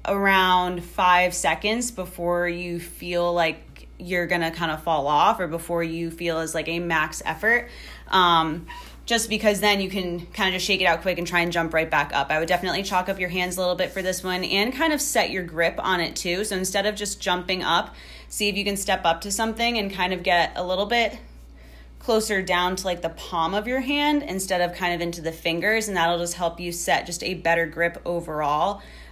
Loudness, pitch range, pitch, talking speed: -23 LUFS, 170-195 Hz, 180 Hz, 230 wpm